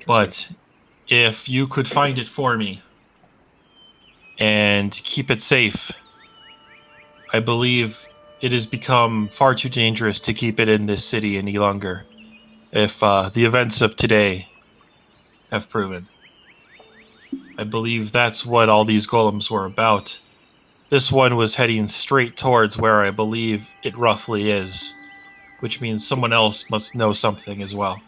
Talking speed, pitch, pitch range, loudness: 140 wpm, 115 Hz, 105-130 Hz, -19 LUFS